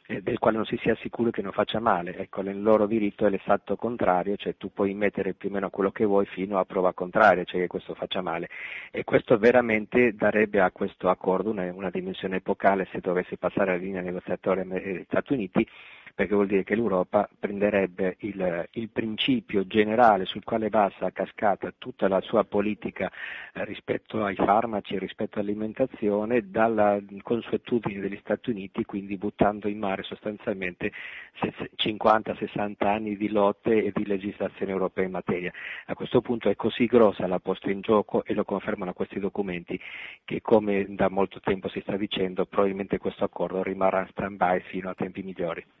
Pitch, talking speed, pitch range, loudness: 100 Hz, 175 wpm, 95-110 Hz, -26 LUFS